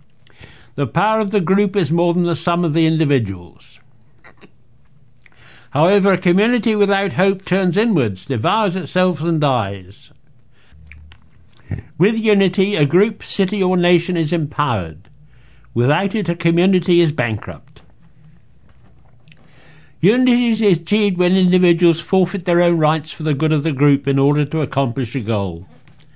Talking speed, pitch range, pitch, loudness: 140 wpm, 130-185 Hz, 160 Hz, -17 LUFS